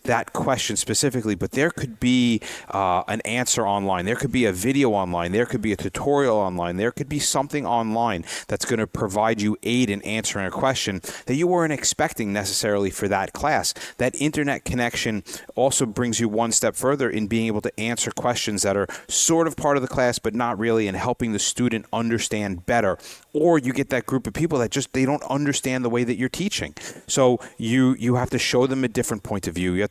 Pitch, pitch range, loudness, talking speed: 120 Hz, 105-130 Hz, -23 LUFS, 220 wpm